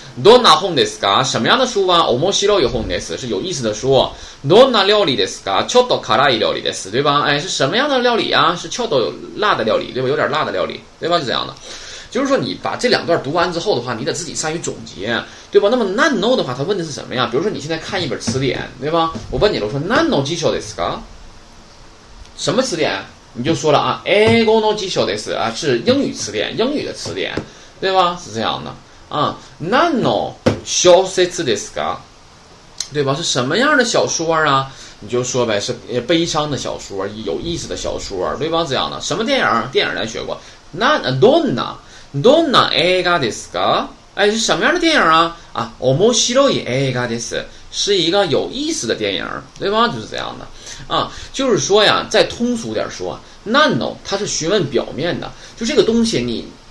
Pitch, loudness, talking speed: 170 Hz, -16 LUFS, 340 characters per minute